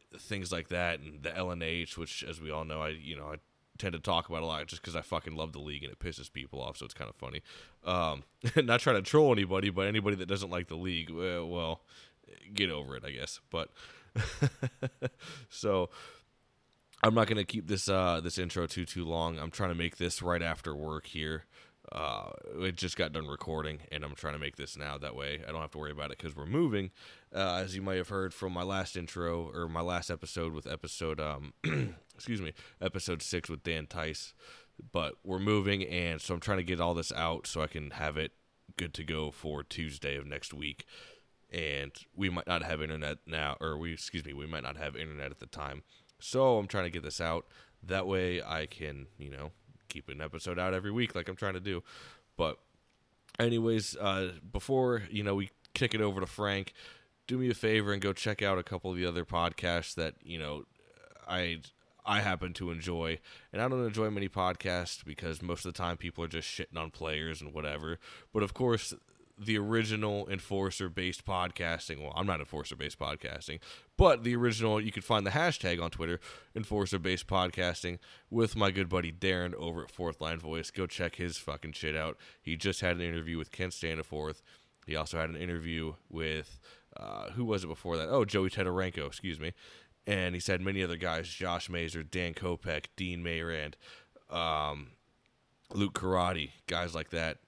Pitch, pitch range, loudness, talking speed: 85 Hz, 80-95 Hz, -35 LUFS, 205 wpm